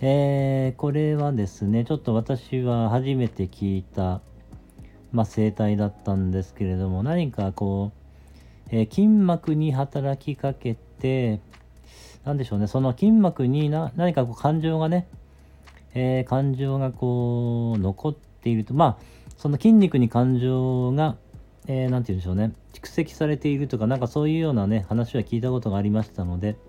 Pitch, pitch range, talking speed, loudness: 125 Hz, 105-140 Hz, 310 characters per minute, -24 LUFS